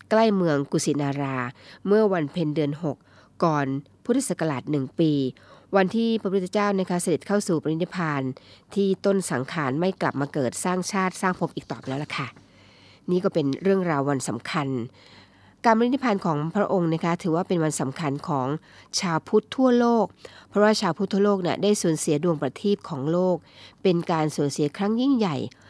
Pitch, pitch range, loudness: 165 Hz, 140-195 Hz, -24 LUFS